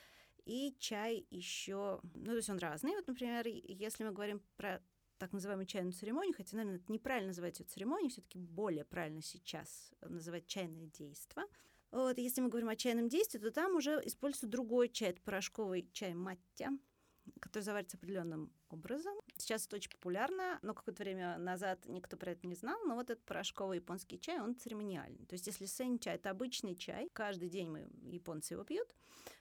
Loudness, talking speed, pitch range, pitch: -43 LUFS, 180 wpm, 180-245 Hz, 205 Hz